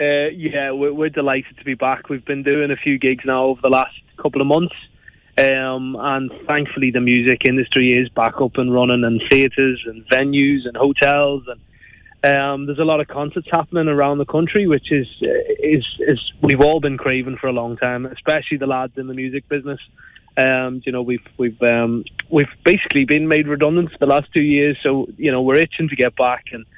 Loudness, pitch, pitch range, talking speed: -17 LUFS, 135 Hz, 130-145 Hz, 210 wpm